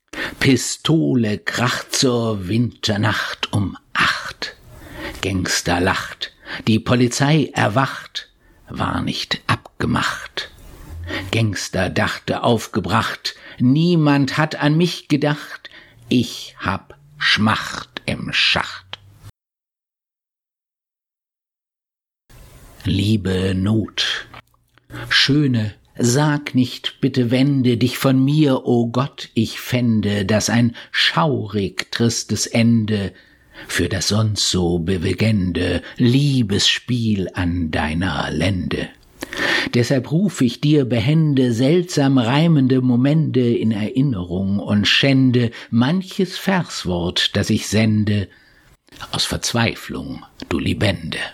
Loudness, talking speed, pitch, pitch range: -18 LUFS, 90 wpm, 120 Hz, 105-135 Hz